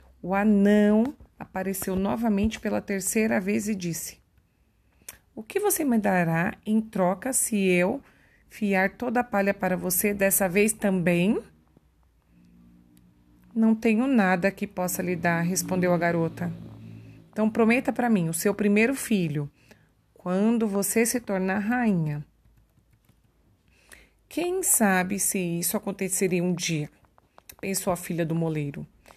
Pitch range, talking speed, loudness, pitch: 170-215 Hz, 130 wpm, -25 LUFS, 195 Hz